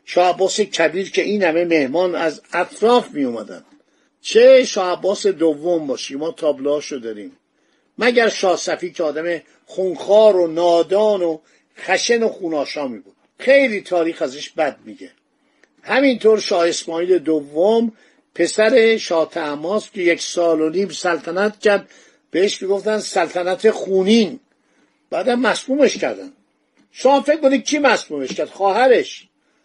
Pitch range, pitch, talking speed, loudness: 170-235 Hz, 195 Hz, 130 wpm, -17 LUFS